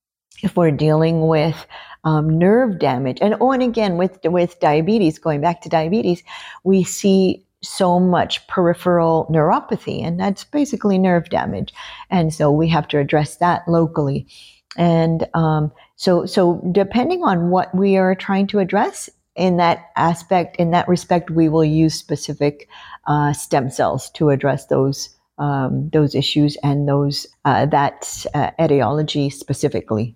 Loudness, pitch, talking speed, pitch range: -18 LUFS, 165 Hz, 150 wpm, 150-185 Hz